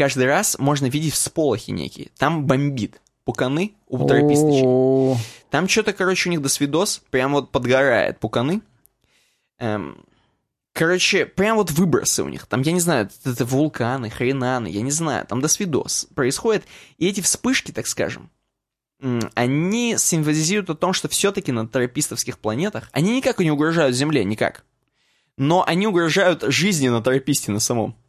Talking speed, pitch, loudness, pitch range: 150 wpm, 140 Hz, -20 LUFS, 125-175 Hz